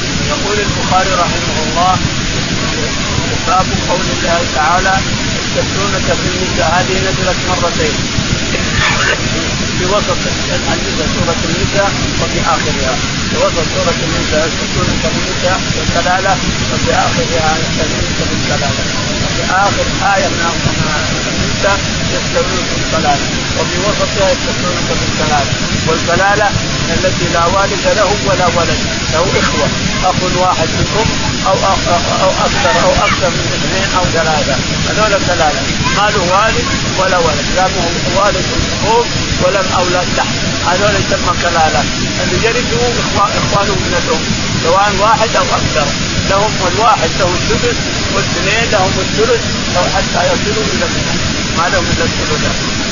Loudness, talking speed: -12 LUFS, 120 wpm